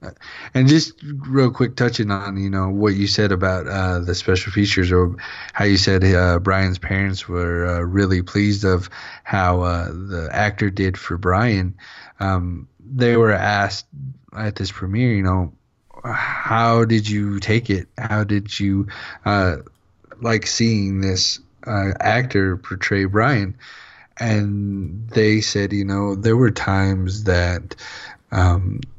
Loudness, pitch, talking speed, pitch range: -19 LUFS, 100 Hz, 145 wpm, 95-110 Hz